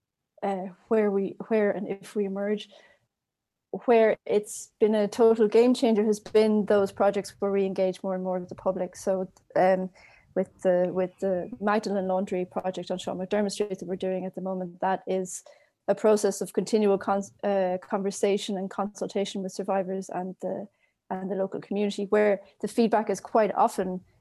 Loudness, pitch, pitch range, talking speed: -27 LUFS, 200 Hz, 185-210 Hz, 180 wpm